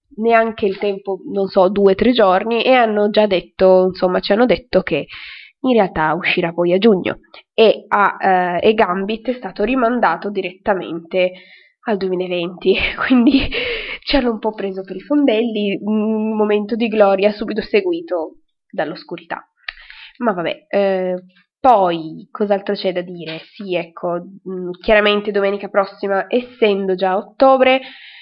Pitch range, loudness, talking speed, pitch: 185-225 Hz, -17 LUFS, 145 wpm, 200 Hz